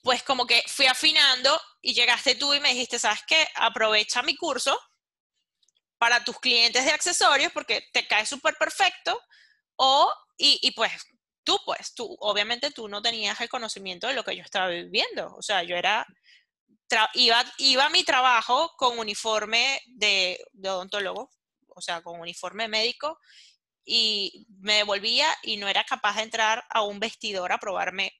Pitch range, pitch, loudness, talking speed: 210-285 Hz, 240 Hz, -23 LUFS, 170 wpm